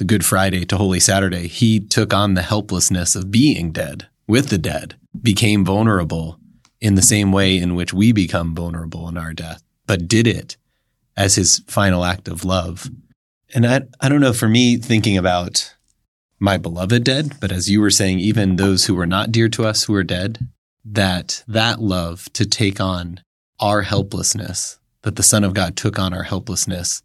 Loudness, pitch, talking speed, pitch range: -17 LUFS, 100 Hz, 190 wpm, 90-110 Hz